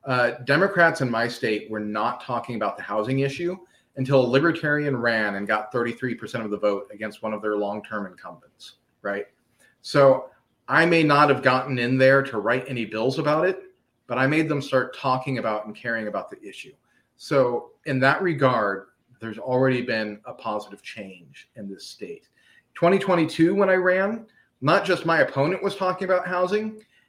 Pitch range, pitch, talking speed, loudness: 110-165 Hz, 130 Hz, 175 wpm, -23 LUFS